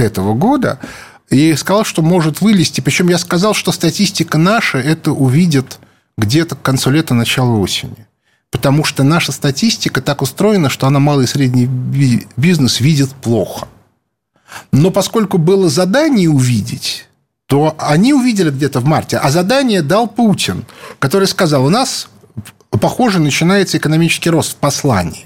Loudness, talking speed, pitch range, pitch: -13 LUFS, 145 wpm, 135-185 Hz, 155 Hz